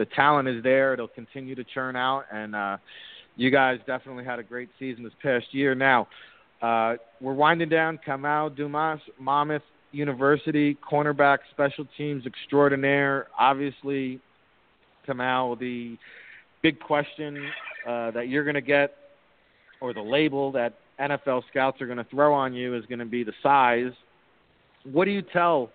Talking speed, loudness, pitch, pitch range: 155 wpm, -25 LUFS, 135 Hz, 125-145 Hz